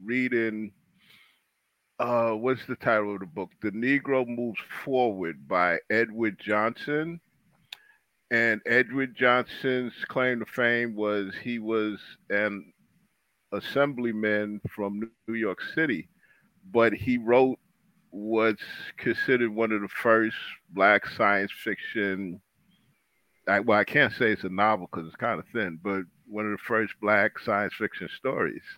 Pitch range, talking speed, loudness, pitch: 105-125 Hz, 135 wpm, -27 LUFS, 115 Hz